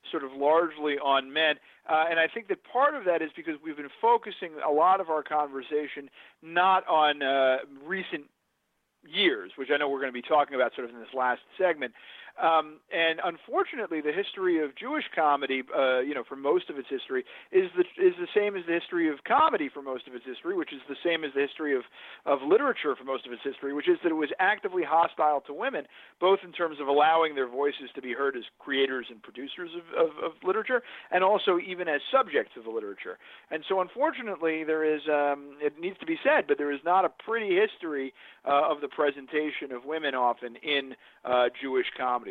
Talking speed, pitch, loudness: 215 wpm, 160 Hz, -28 LUFS